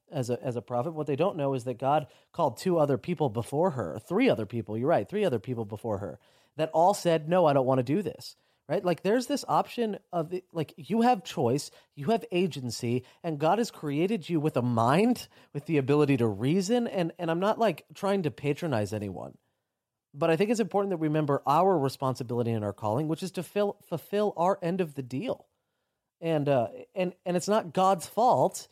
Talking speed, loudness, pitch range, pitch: 215 wpm, -28 LUFS, 130-185 Hz, 160 Hz